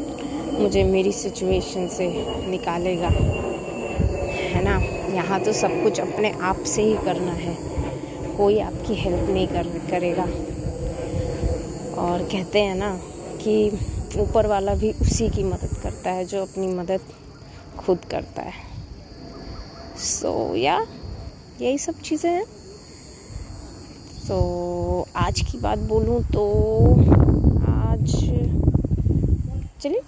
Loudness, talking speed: -23 LUFS, 120 wpm